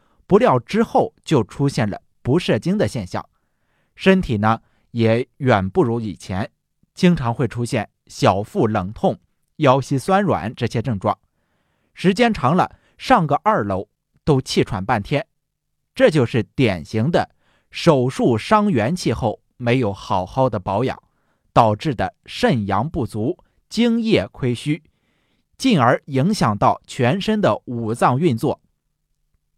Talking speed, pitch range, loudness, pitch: 195 characters per minute, 110-170 Hz, -19 LUFS, 125 Hz